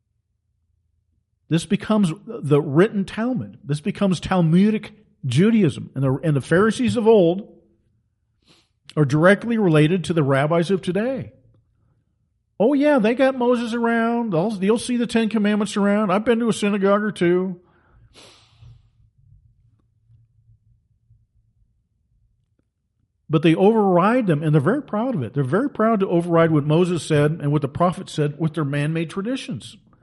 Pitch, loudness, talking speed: 165 Hz, -20 LUFS, 140 wpm